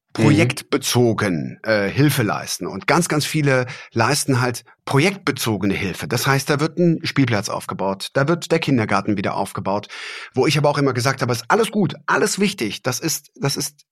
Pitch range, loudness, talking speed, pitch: 120-155 Hz, -19 LUFS, 175 wpm, 140 Hz